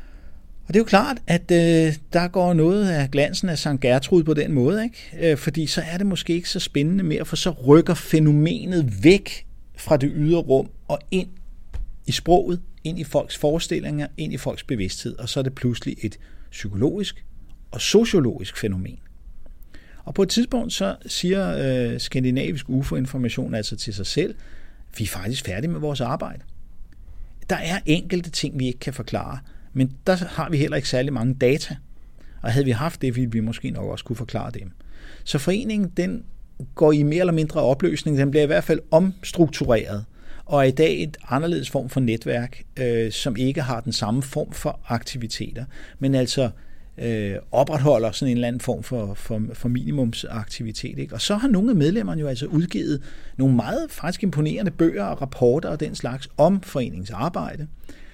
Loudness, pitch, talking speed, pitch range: -22 LUFS, 140 Hz, 185 wpm, 120-165 Hz